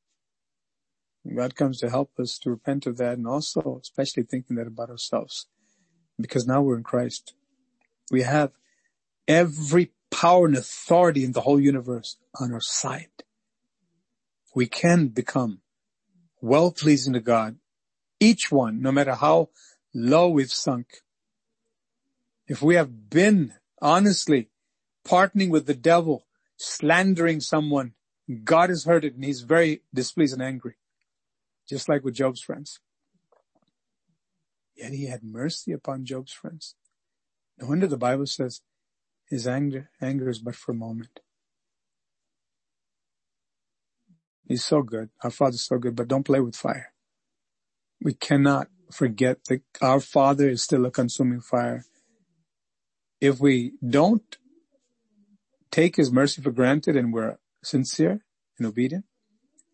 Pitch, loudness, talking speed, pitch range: 140 Hz, -23 LUFS, 130 wpm, 125-170 Hz